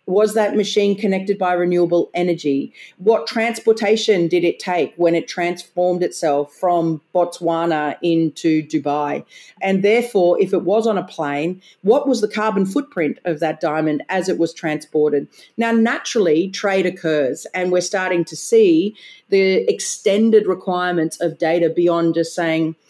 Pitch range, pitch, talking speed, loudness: 165-205 Hz, 180 Hz, 150 wpm, -18 LUFS